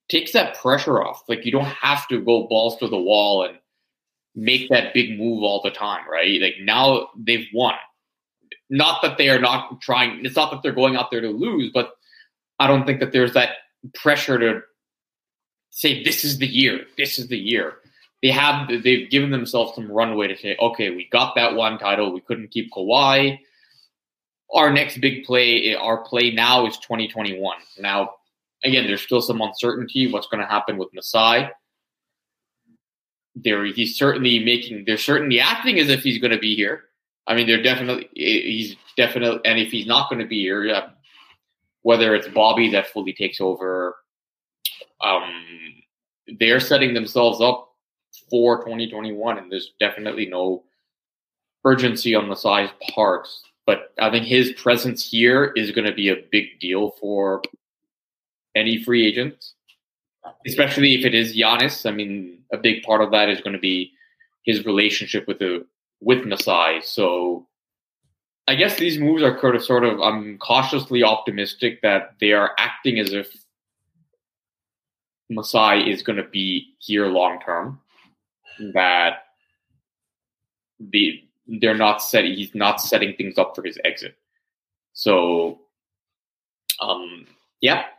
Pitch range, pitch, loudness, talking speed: 105-130 Hz, 115 Hz, -19 LUFS, 155 wpm